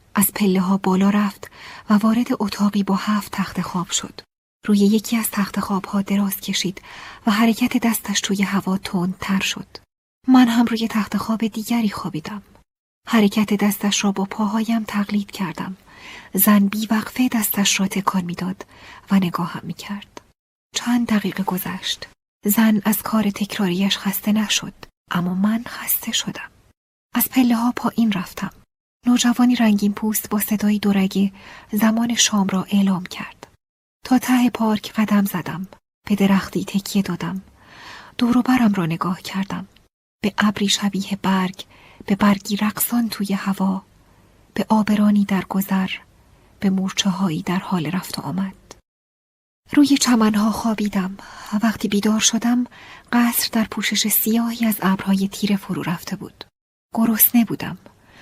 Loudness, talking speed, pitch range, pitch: -20 LUFS, 140 wpm, 195-220 Hz, 205 Hz